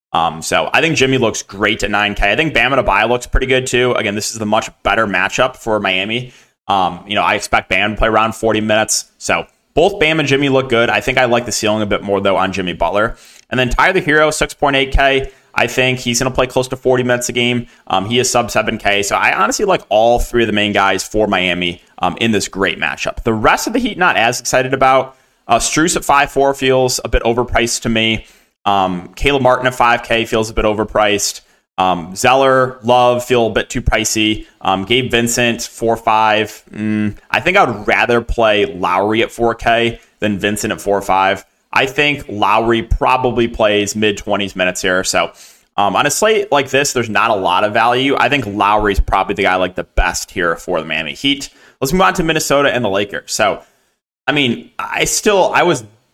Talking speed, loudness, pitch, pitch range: 215 wpm, -14 LUFS, 115 Hz, 105-130 Hz